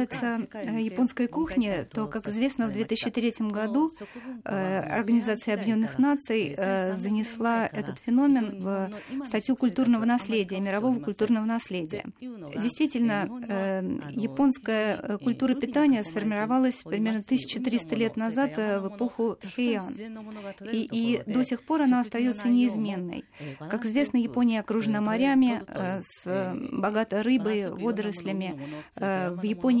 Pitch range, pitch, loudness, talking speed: 205-245 Hz, 225 Hz, -27 LUFS, 105 wpm